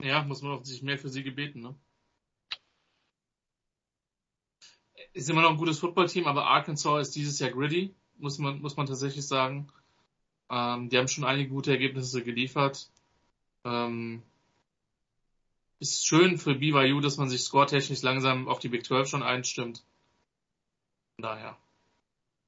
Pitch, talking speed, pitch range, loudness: 140 Hz, 145 wpm, 130-145 Hz, -28 LUFS